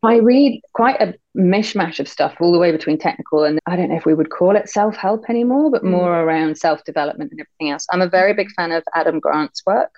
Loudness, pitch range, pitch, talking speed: -17 LUFS, 160-205 Hz, 175 Hz, 245 wpm